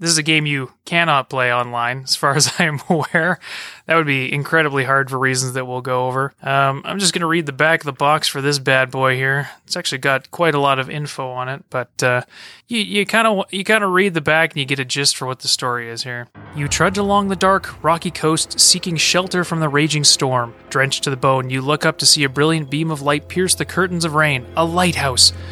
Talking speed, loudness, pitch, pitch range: 250 wpm, -17 LUFS, 145 Hz, 130-165 Hz